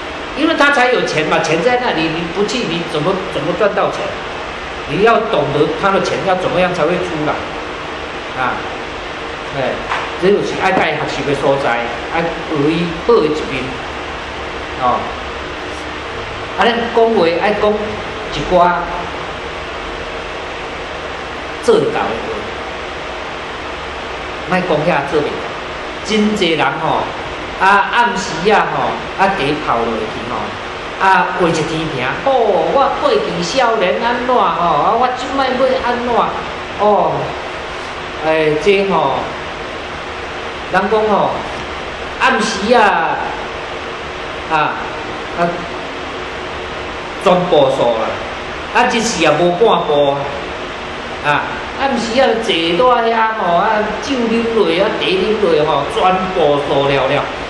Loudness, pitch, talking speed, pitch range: -16 LUFS, 190 Hz, 170 characters per minute, 160-235 Hz